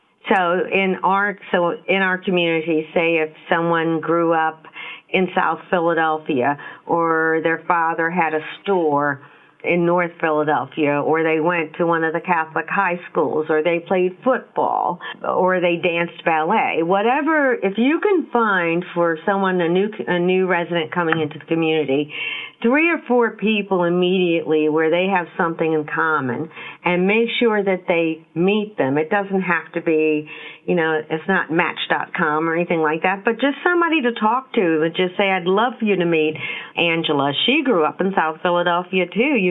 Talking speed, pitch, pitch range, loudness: 175 wpm, 170 Hz, 160-190 Hz, -19 LUFS